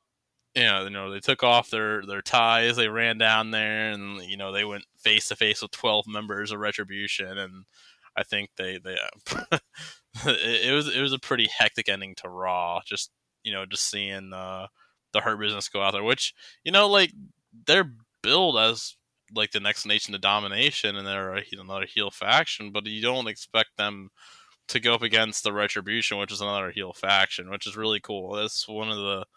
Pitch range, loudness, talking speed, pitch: 100-115 Hz, -25 LUFS, 200 wpm, 105 Hz